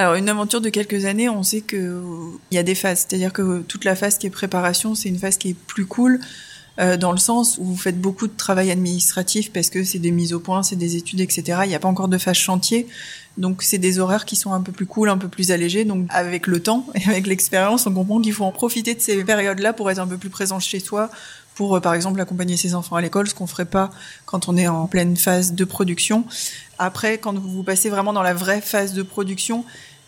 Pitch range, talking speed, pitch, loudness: 180-205 Hz, 255 wpm, 190 Hz, -20 LUFS